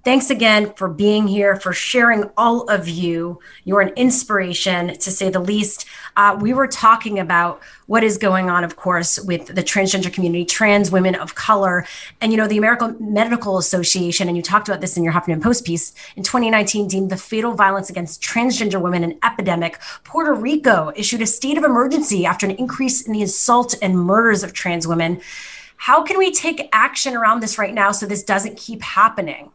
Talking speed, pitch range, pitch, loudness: 195 wpm, 185-235 Hz, 205 Hz, -17 LUFS